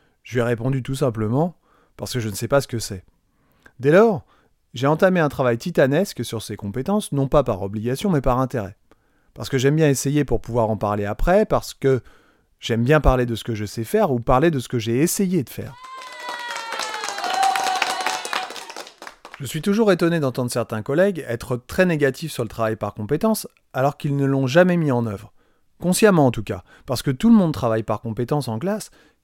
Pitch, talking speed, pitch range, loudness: 135 Hz, 205 wpm, 115-175 Hz, -21 LUFS